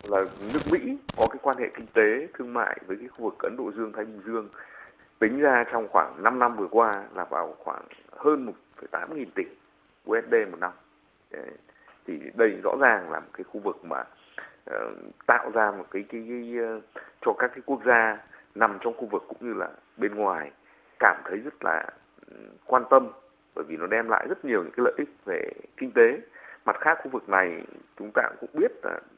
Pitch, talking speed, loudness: 265 Hz, 205 wpm, -26 LUFS